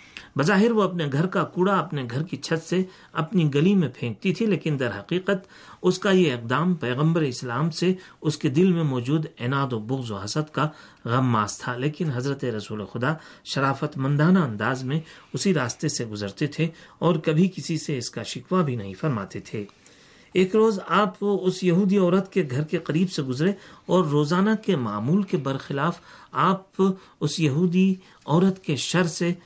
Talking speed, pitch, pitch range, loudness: 180 wpm, 160 Hz, 135-185 Hz, -24 LUFS